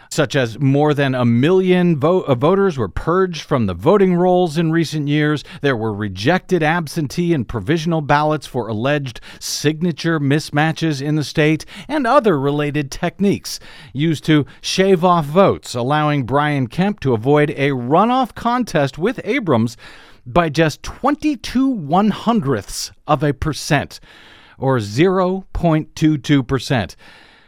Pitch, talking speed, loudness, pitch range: 155 Hz, 135 wpm, -17 LUFS, 140-180 Hz